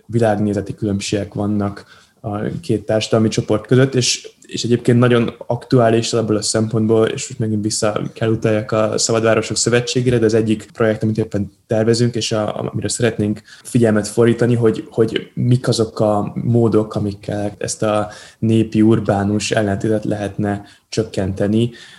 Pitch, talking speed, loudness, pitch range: 110 Hz, 140 wpm, -17 LUFS, 105-115 Hz